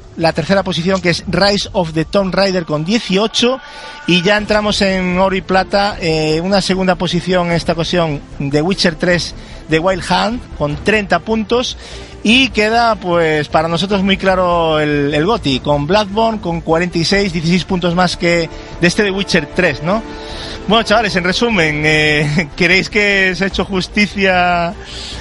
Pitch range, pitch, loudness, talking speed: 165-200 Hz, 185 Hz, -14 LUFS, 165 wpm